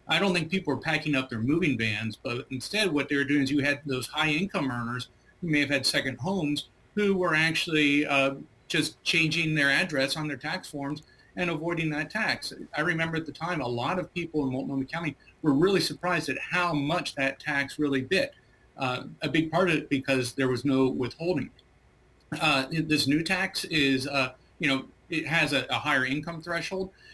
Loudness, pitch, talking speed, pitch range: -27 LUFS, 150 Hz, 205 wpm, 135-165 Hz